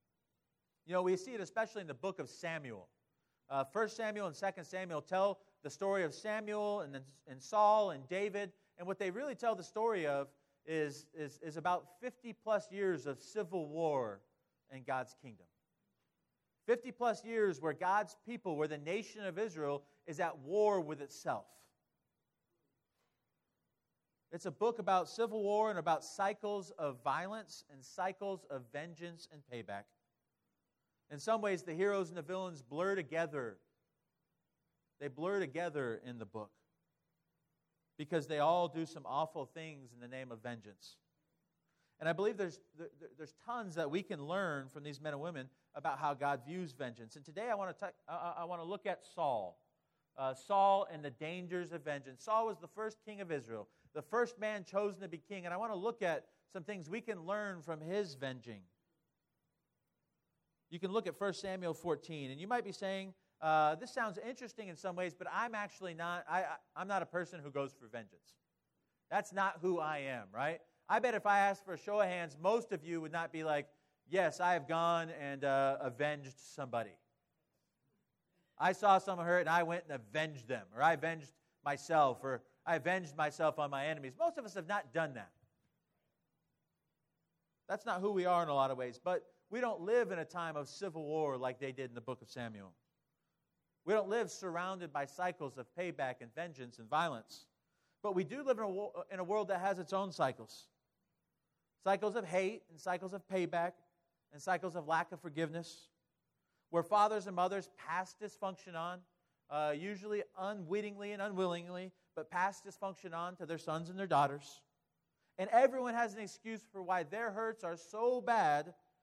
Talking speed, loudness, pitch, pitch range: 185 wpm, -39 LUFS, 175 Hz, 150-195 Hz